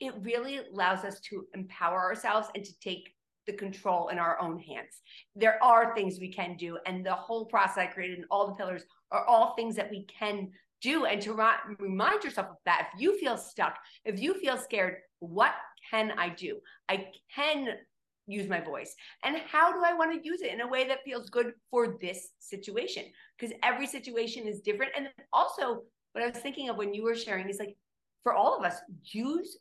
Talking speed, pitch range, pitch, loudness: 210 wpm, 190-245 Hz, 215 Hz, -31 LUFS